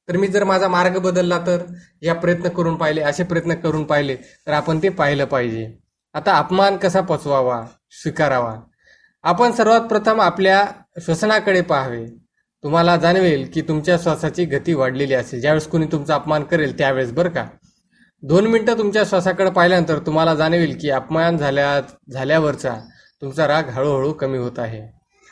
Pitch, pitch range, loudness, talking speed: 160 Hz, 140-180 Hz, -18 LUFS, 150 wpm